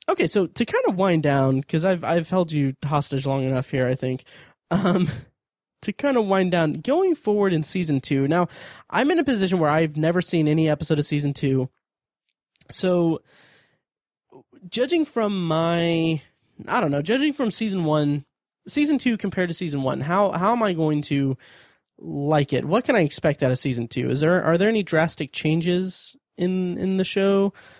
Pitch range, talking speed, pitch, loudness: 145-195 Hz, 190 wpm, 165 Hz, -22 LUFS